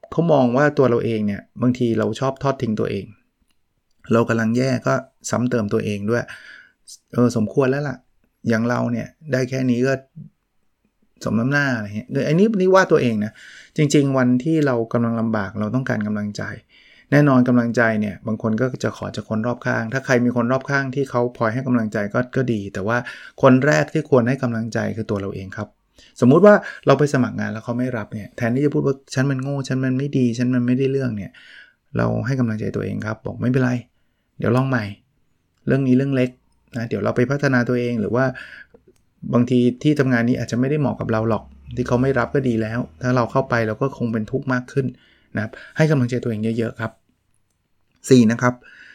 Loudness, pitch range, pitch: -20 LUFS, 115-135 Hz, 125 Hz